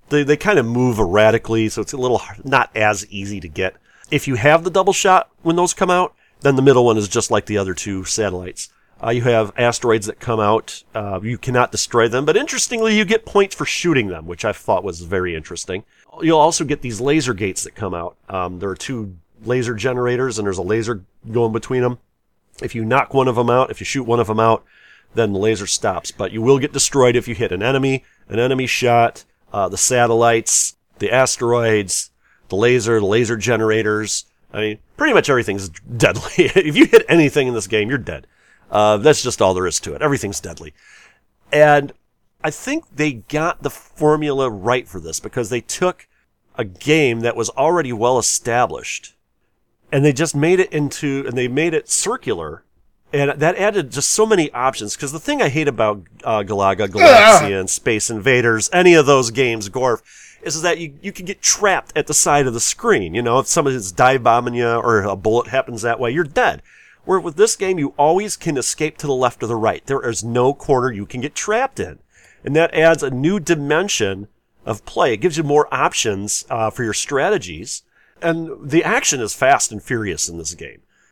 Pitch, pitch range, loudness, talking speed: 125 Hz, 110-150 Hz, -17 LUFS, 210 wpm